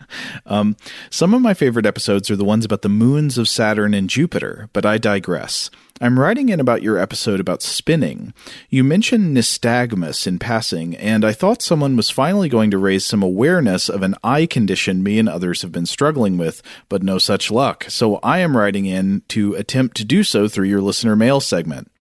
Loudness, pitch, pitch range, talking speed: -17 LUFS, 110 Hz, 100-130 Hz, 200 wpm